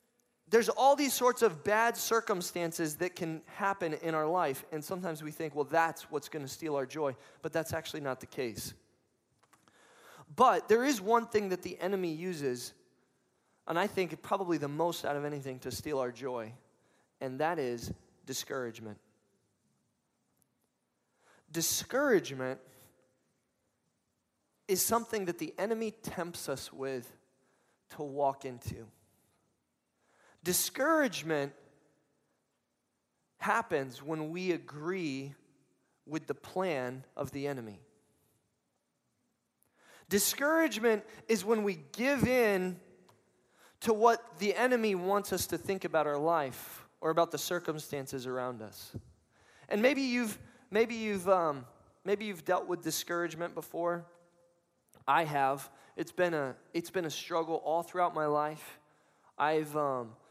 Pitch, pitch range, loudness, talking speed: 165 Hz, 140-195 Hz, -33 LUFS, 130 wpm